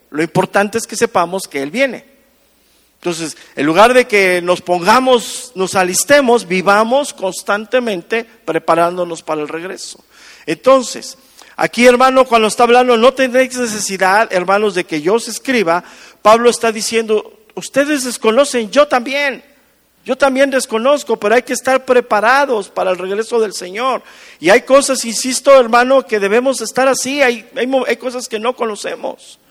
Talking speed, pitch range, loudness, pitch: 150 wpm, 195-260 Hz, -13 LUFS, 230 Hz